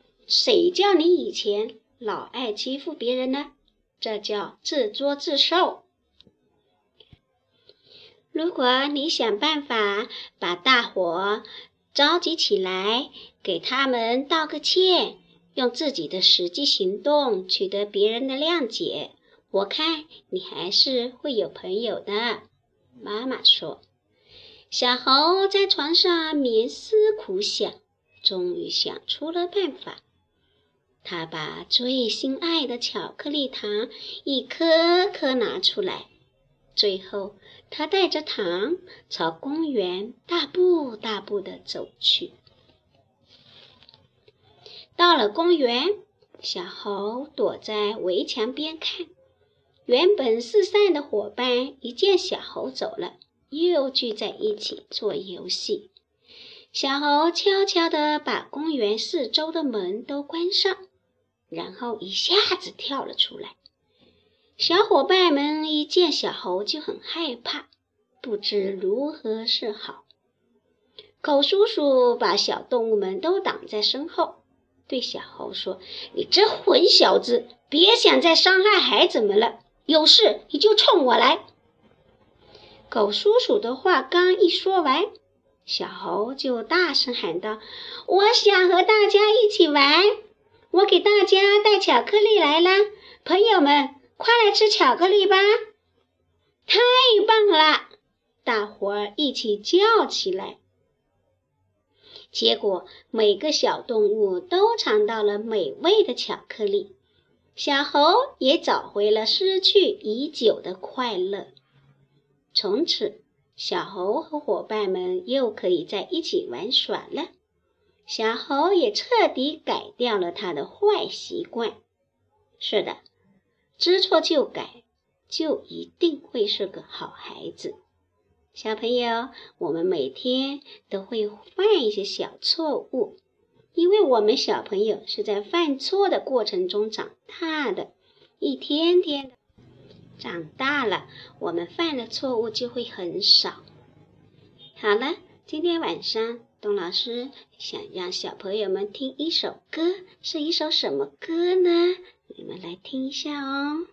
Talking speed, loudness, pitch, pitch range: 170 characters per minute, -22 LUFS, 330 Hz, 245-405 Hz